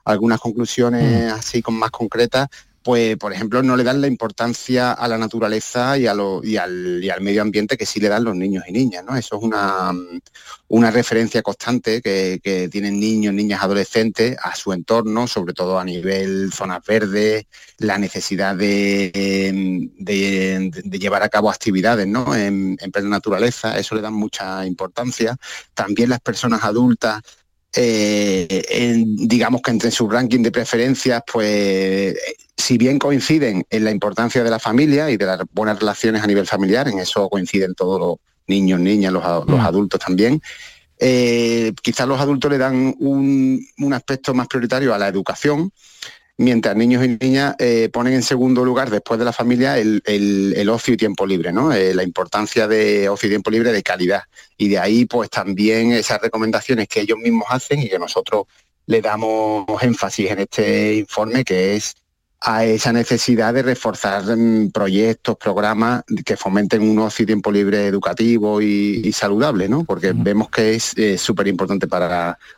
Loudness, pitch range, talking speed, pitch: -18 LUFS, 100-120 Hz, 175 wpm, 110 Hz